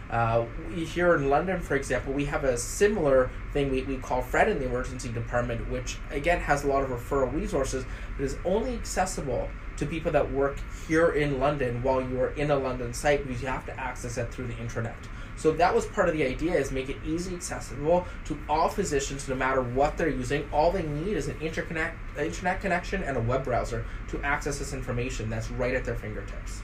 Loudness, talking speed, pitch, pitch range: -28 LUFS, 220 wpm, 135 Hz, 120-150 Hz